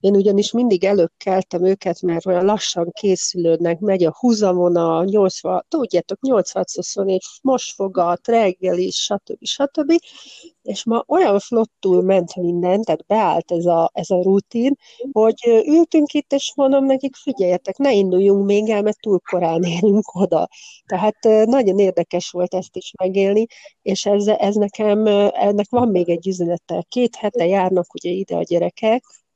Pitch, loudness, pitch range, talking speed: 200 Hz, -18 LUFS, 180-230 Hz, 155 wpm